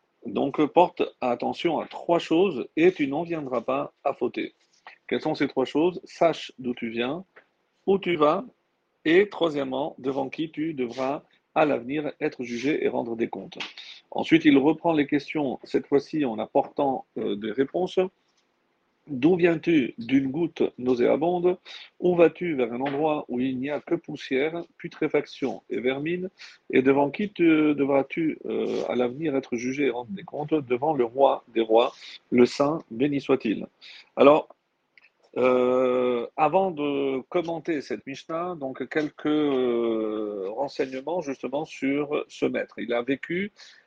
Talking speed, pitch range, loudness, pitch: 150 wpm, 130-180 Hz, -25 LUFS, 150 Hz